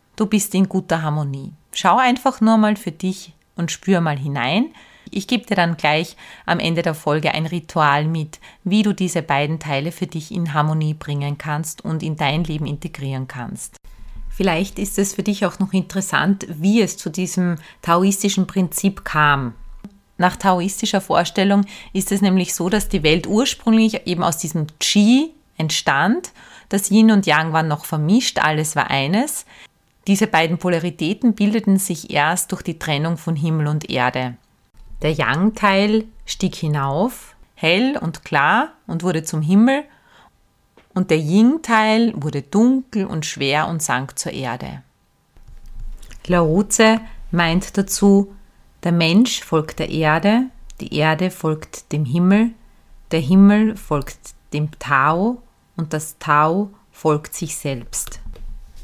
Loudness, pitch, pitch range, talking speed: -18 LUFS, 175 Hz, 155-200 Hz, 150 wpm